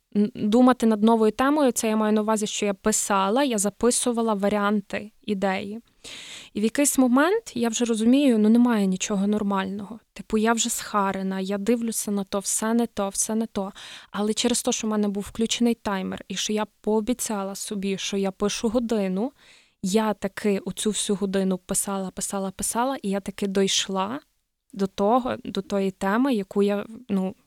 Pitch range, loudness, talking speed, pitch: 200-230 Hz, -24 LUFS, 175 wpm, 210 Hz